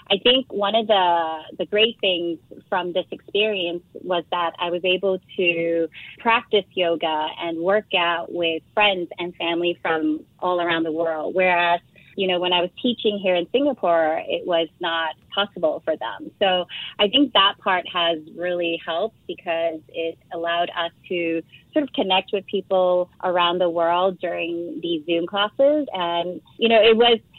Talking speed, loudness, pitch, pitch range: 170 wpm, -21 LUFS, 180 Hz, 170-200 Hz